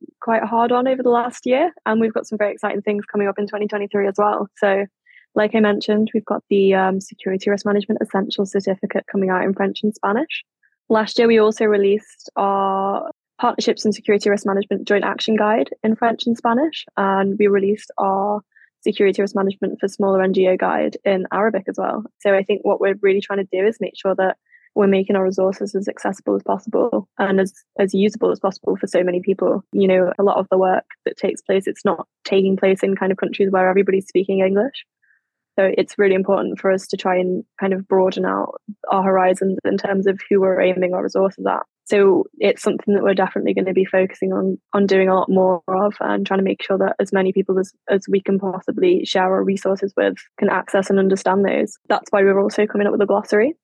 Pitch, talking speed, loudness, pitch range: 200 Hz, 220 wpm, -19 LUFS, 190-210 Hz